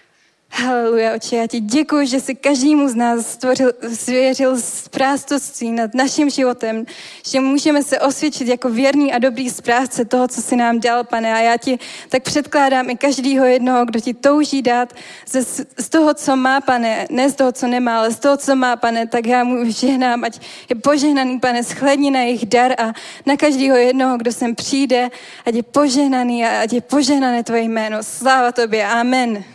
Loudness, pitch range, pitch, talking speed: -16 LUFS, 235-275 Hz, 255 Hz, 185 wpm